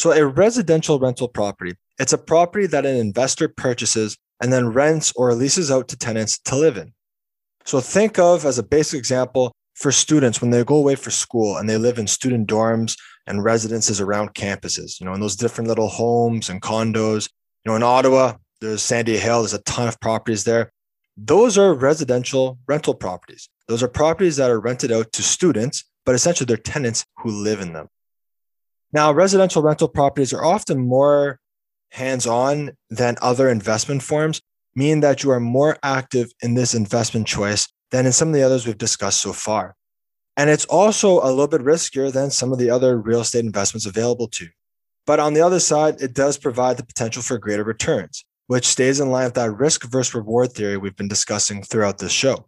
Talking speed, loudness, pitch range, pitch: 195 wpm, -19 LUFS, 115-140 Hz, 125 Hz